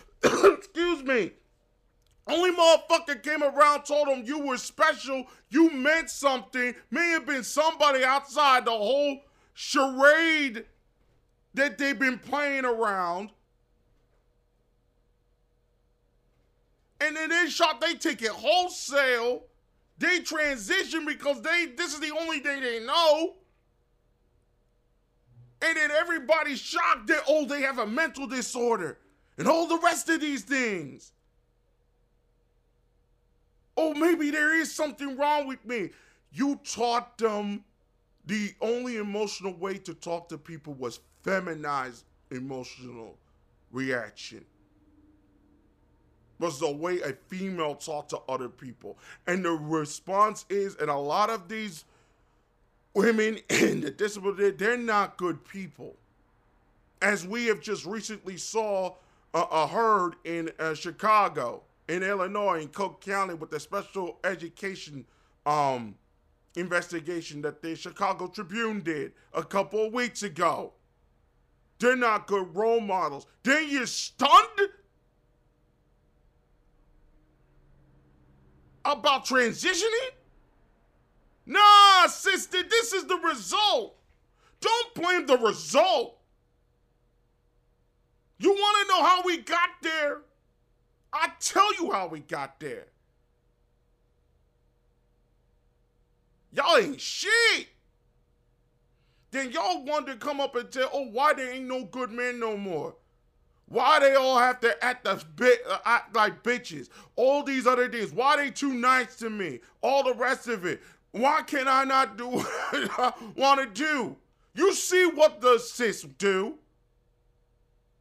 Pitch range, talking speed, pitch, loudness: 185-300 Hz, 125 wpm, 245 Hz, -26 LUFS